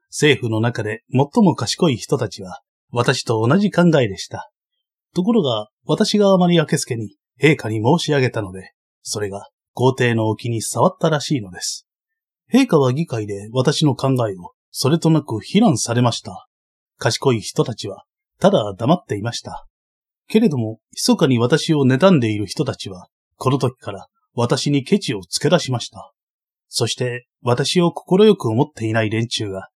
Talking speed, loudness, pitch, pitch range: 310 characters per minute, -18 LUFS, 130 Hz, 110-165 Hz